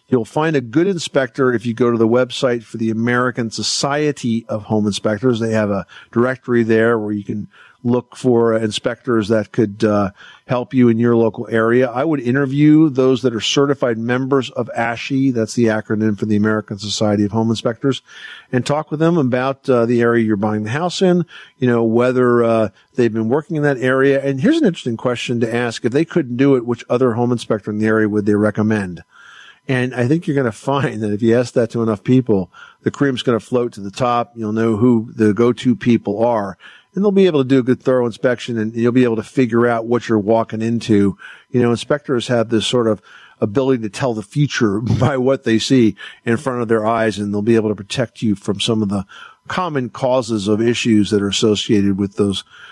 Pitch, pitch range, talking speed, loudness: 120 Hz, 110-130 Hz, 225 wpm, -17 LUFS